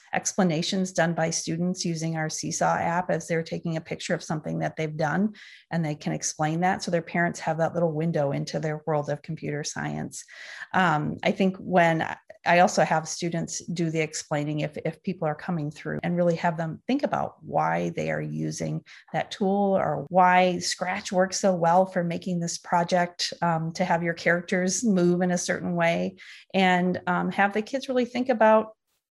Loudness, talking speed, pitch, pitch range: -26 LUFS, 190 wpm, 170 Hz, 160-185 Hz